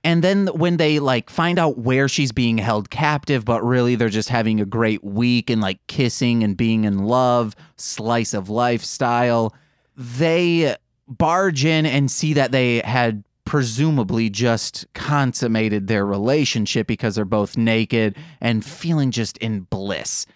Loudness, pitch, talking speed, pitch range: -20 LUFS, 120 Hz, 155 wpm, 110-145 Hz